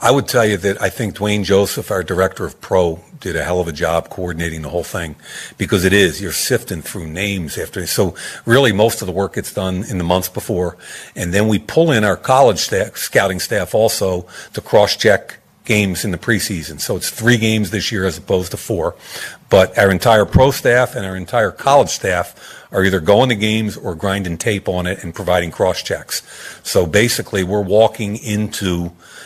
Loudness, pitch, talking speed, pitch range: -16 LUFS, 100 Hz, 205 wpm, 90-110 Hz